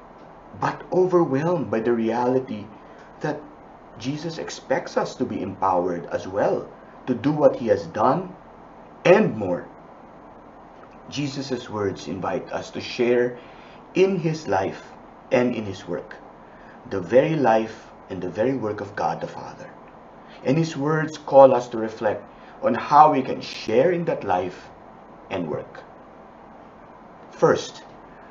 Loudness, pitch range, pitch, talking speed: -23 LUFS, 110-155 Hz, 125 Hz, 135 wpm